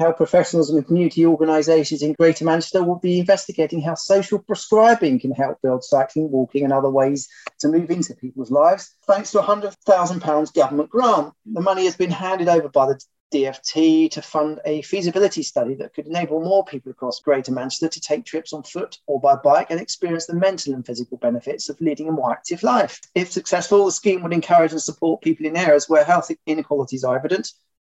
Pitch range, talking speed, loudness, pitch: 145-180 Hz, 200 wpm, -19 LUFS, 160 Hz